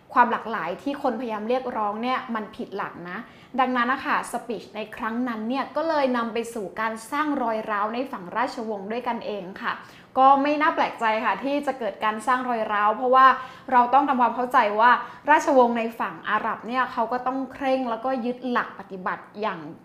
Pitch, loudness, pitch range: 240 Hz, -24 LUFS, 220-260 Hz